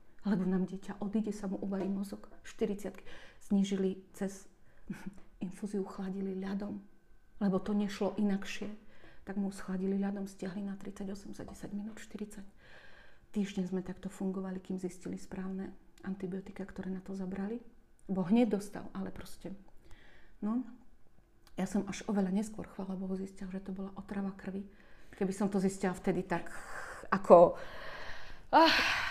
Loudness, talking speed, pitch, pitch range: -35 LUFS, 140 wpm, 195 Hz, 190-205 Hz